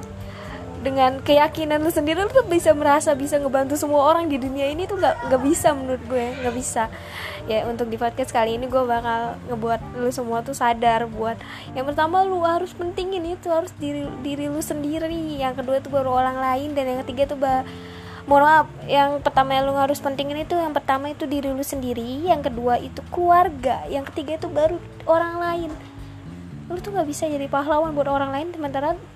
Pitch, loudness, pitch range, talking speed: 280 Hz, -22 LUFS, 255-315 Hz, 190 wpm